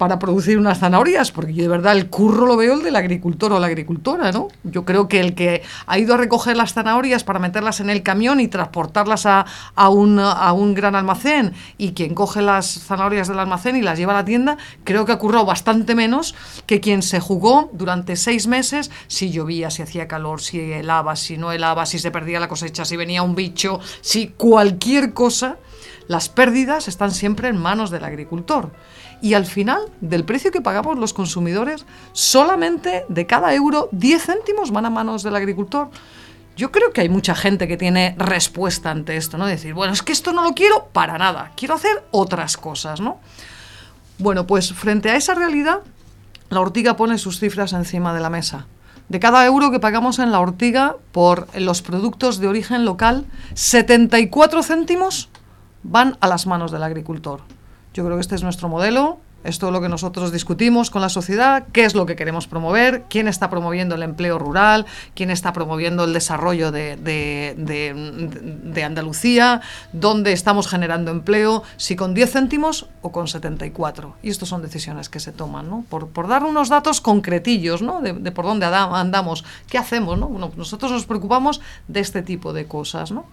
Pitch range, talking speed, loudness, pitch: 170-235 Hz, 190 wpm, -18 LUFS, 195 Hz